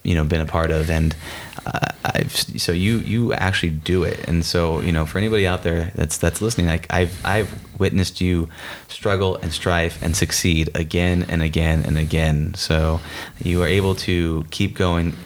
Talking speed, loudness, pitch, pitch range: 190 wpm, -20 LUFS, 85 Hz, 80-95 Hz